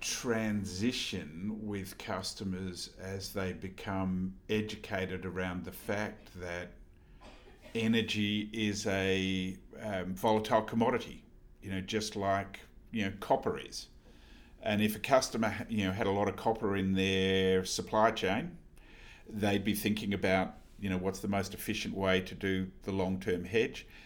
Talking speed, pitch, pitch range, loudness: 140 wpm, 100 Hz, 95-105 Hz, -34 LUFS